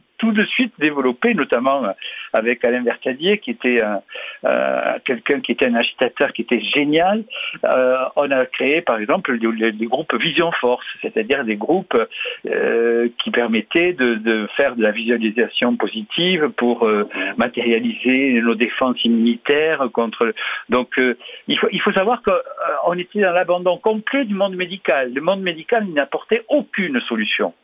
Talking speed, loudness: 155 wpm, -18 LUFS